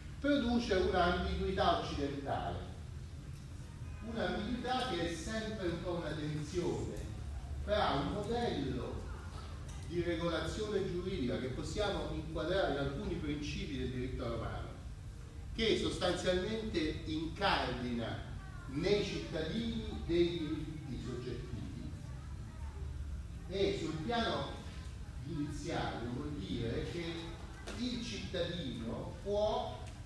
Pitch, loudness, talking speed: 140 Hz, -38 LUFS, 85 wpm